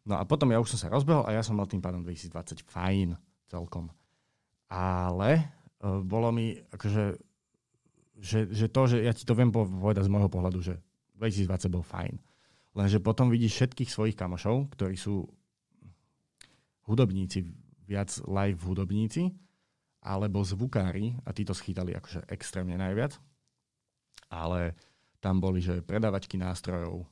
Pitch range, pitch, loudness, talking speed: 90-115 Hz, 100 Hz, -30 LUFS, 145 wpm